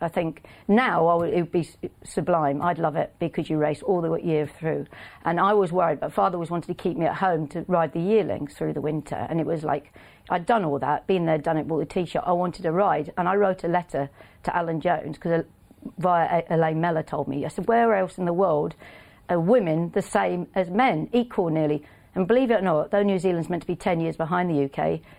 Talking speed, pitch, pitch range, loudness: 240 wpm, 170 Hz, 155-185 Hz, -24 LUFS